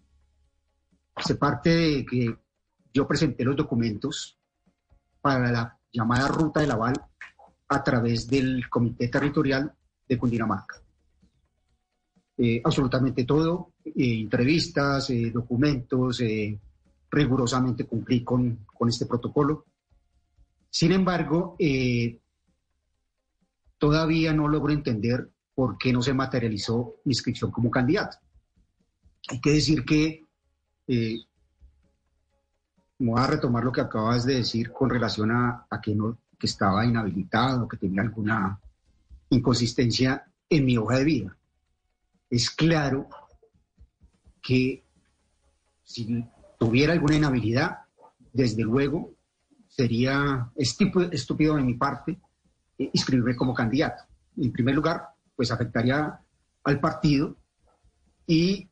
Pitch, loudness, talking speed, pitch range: 125 Hz, -25 LUFS, 110 wpm, 105-145 Hz